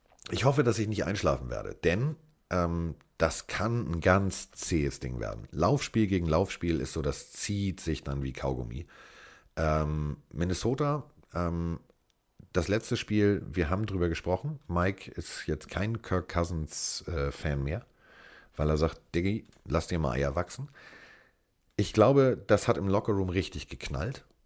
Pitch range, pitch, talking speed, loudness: 80-105 Hz, 90 Hz, 150 wpm, -30 LUFS